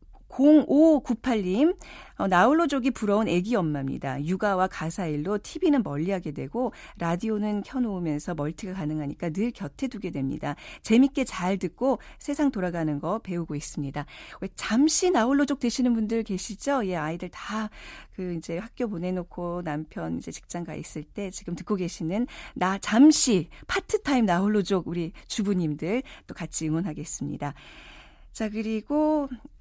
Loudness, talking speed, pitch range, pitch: -26 LUFS, 310 characters per minute, 170-245 Hz, 195 Hz